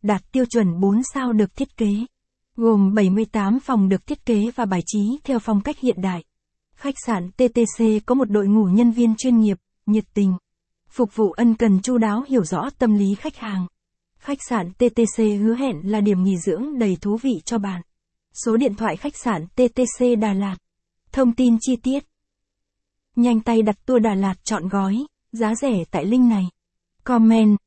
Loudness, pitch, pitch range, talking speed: -20 LUFS, 225 Hz, 200-245 Hz, 190 wpm